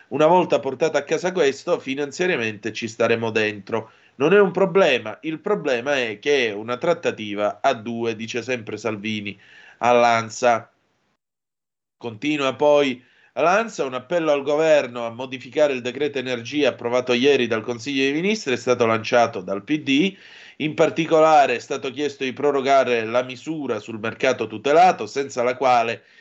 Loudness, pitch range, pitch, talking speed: -21 LUFS, 115-150 Hz, 130 Hz, 145 wpm